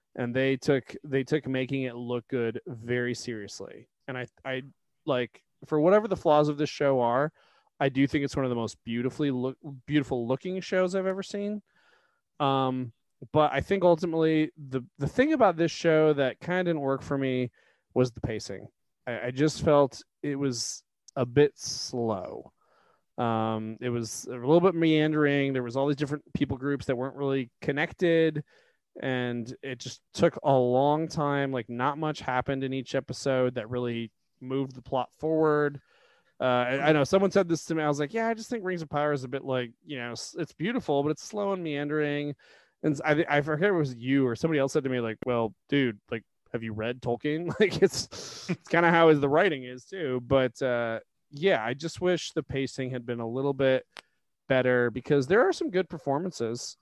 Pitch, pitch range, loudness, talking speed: 140 Hz, 125-155 Hz, -28 LUFS, 200 wpm